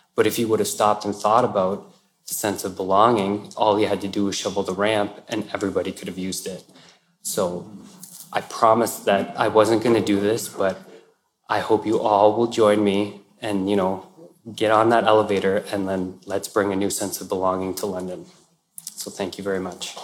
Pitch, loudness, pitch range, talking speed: 100 Hz, -22 LUFS, 95-105 Hz, 205 wpm